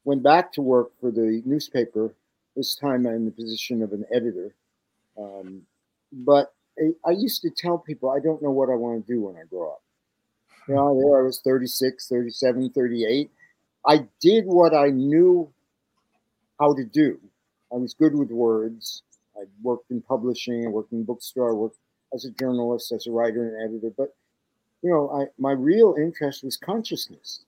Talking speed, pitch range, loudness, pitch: 185 wpm, 115-145 Hz, -23 LUFS, 130 Hz